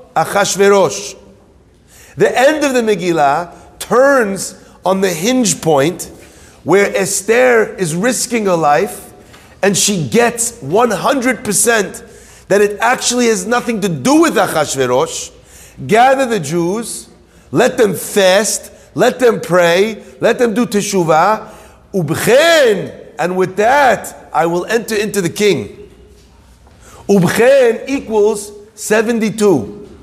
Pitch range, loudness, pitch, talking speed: 185-235 Hz, -13 LUFS, 210 Hz, 110 wpm